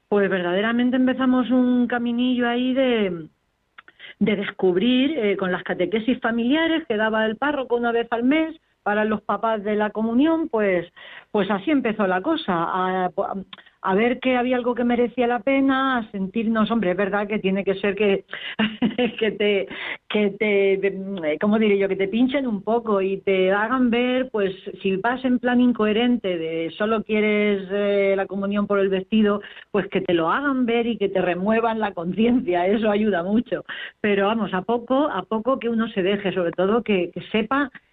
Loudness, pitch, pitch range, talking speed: -22 LUFS, 215 Hz, 195-245 Hz, 185 wpm